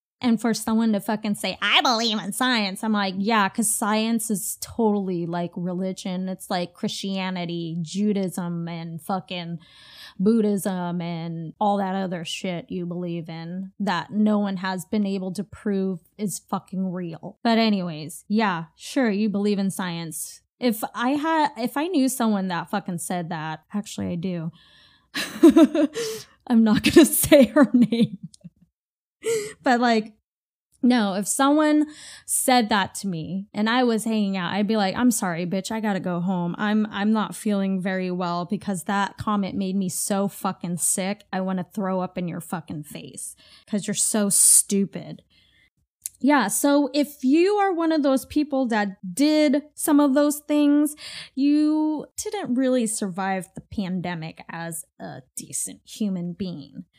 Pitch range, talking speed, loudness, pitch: 180-240 Hz, 160 wpm, -23 LUFS, 205 Hz